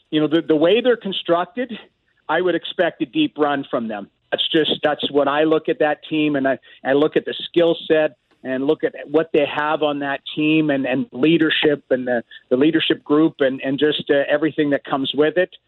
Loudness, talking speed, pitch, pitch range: -19 LUFS, 220 wpm, 155 Hz, 140-160 Hz